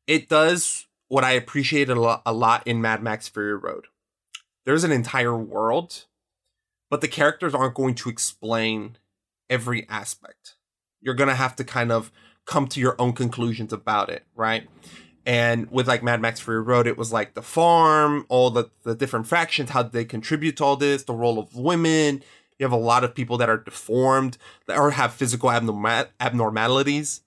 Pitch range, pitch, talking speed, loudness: 115-140 Hz, 125 Hz, 185 wpm, -22 LUFS